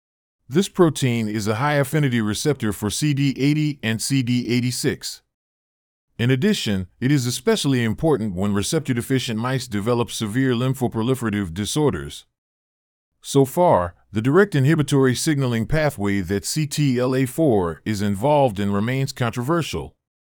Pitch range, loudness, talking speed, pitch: 105-140 Hz, -21 LUFS, 115 wpm, 125 Hz